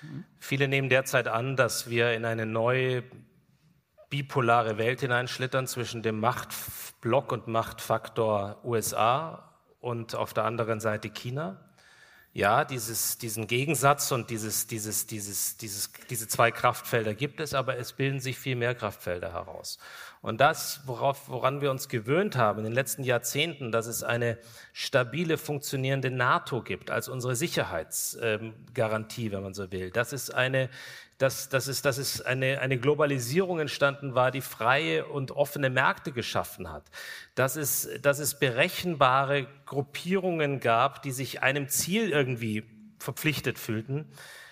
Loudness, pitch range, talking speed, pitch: -28 LUFS, 115-140 Hz, 145 wpm, 130 Hz